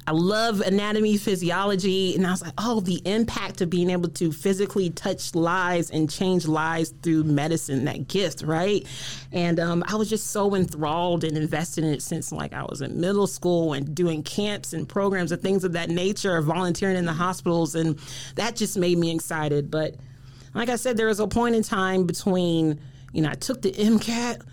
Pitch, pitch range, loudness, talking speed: 175 Hz, 155-195 Hz, -24 LUFS, 190 wpm